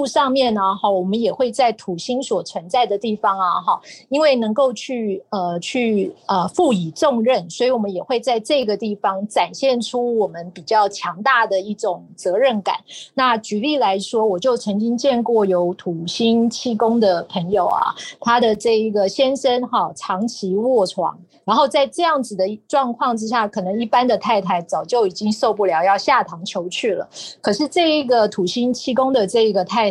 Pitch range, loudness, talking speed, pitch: 195-255 Hz, -19 LUFS, 270 characters per minute, 225 Hz